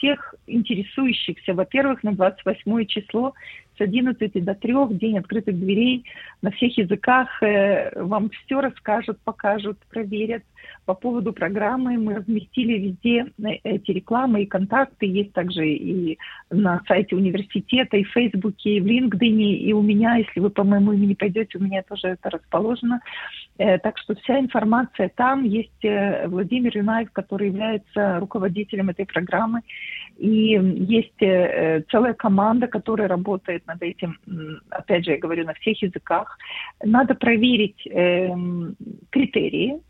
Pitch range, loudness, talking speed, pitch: 190-230 Hz, -22 LUFS, 130 wpm, 210 Hz